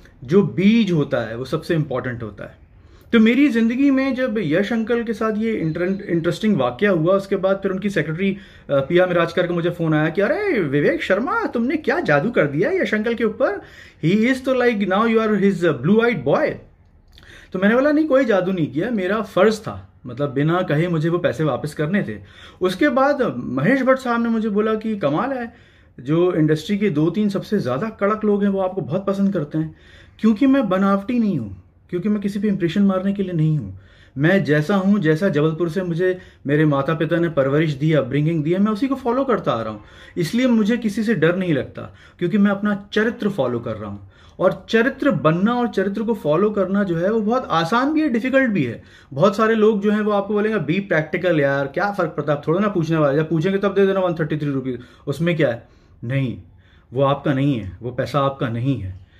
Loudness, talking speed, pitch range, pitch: -19 LUFS, 220 wpm, 145-215 Hz, 180 Hz